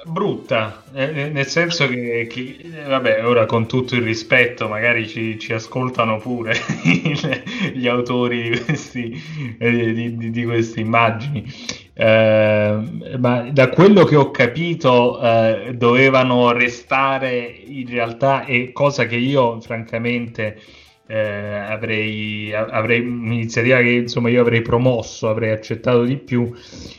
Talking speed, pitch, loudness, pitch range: 120 wpm, 120 Hz, -18 LUFS, 115-130 Hz